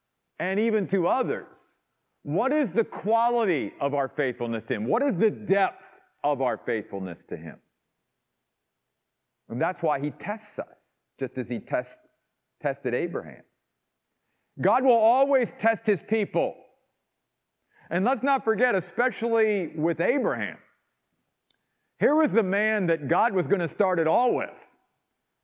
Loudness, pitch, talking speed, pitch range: -26 LUFS, 205 Hz, 140 wpm, 165-235 Hz